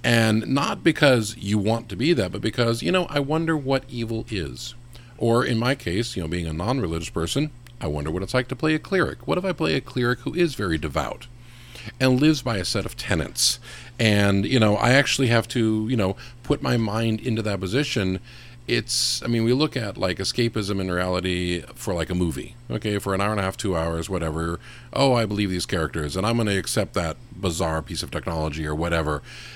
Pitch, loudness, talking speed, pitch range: 115 Hz, -23 LUFS, 225 wpm, 95-125 Hz